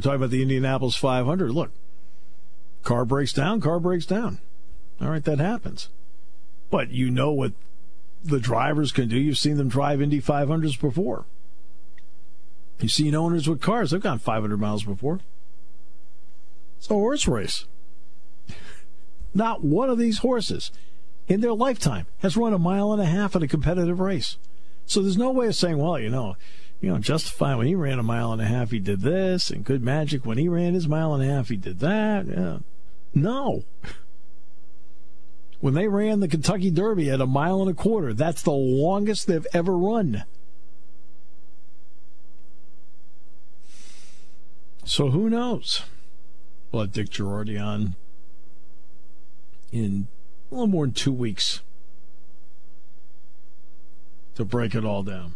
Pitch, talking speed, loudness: 115 Hz, 155 wpm, -24 LUFS